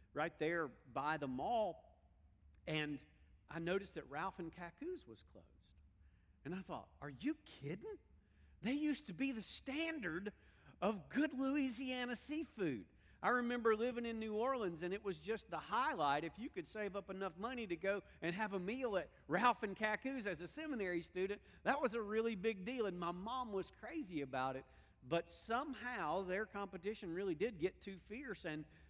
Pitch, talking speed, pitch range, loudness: 200 Hz, 180 wpm, 165-245 Hz, -43 LUFS